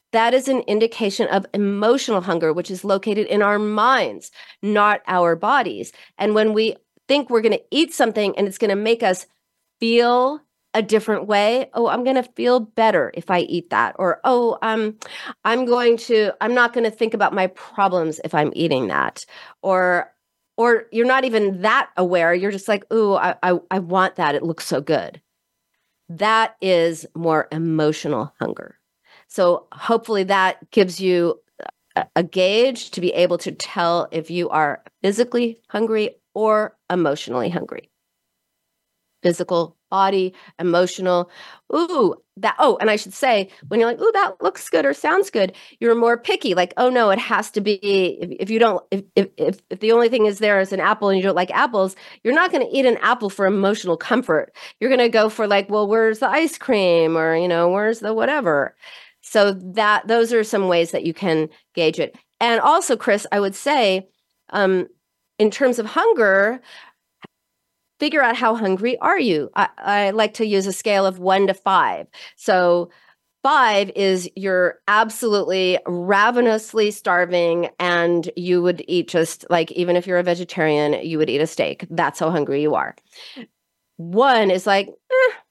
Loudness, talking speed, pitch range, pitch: -19 LUFS, 180 wpm, 180-230 Hz, 200 Hz